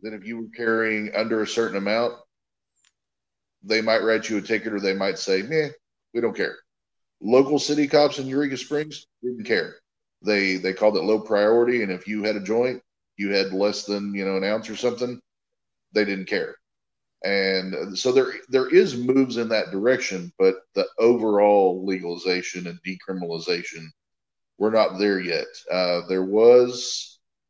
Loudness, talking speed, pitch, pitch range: -23 LUFS, 170 wpm, 105 Hz, 95-125 Hz